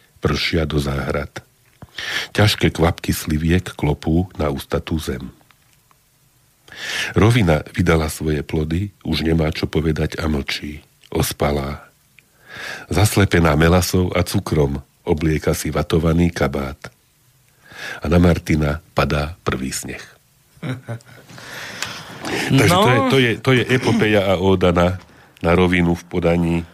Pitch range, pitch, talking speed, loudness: 75-100 Hz, 85 Hz, 110 wpm, -18 LUFS